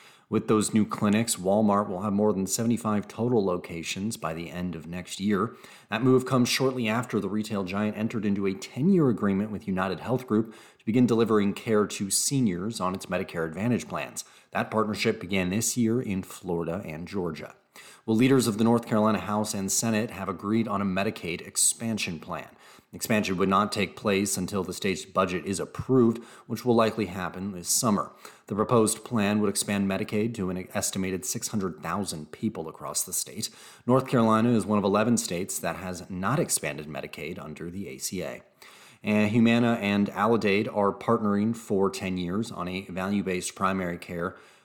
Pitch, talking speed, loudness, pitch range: 105 Hz, 180 wpm, -27 LUFS, 95-115 Hz